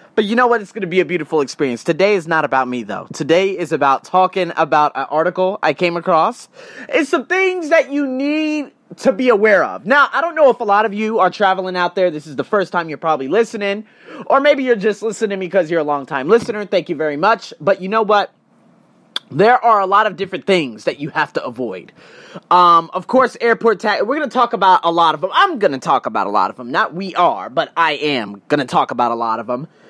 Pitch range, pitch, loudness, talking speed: 160-230 Hz, 190 Hz, -16 LUFS, 255 wpm